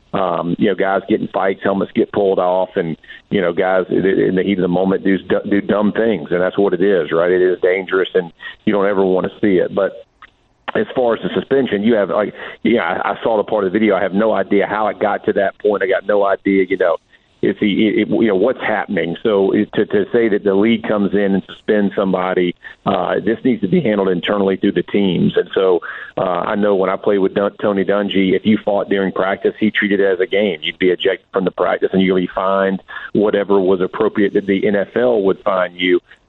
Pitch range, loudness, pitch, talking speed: 95-105 Hz, -16 LUFS, 95 Hz, 235 wpm